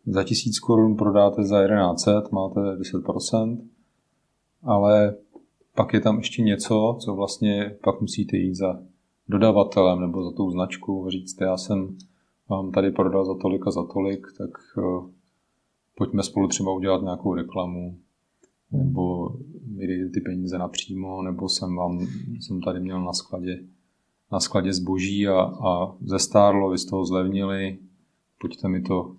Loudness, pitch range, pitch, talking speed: -24 LUFS, 90-100 Hz, 95 Hz, 145 wpm